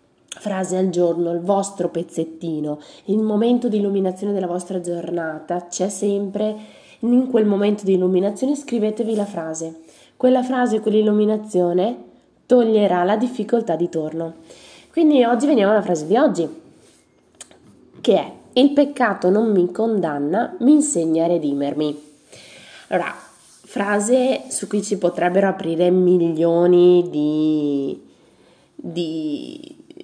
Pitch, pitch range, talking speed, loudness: 190 Hz, 170-220 Hz, 120 wpm, -19 LUFS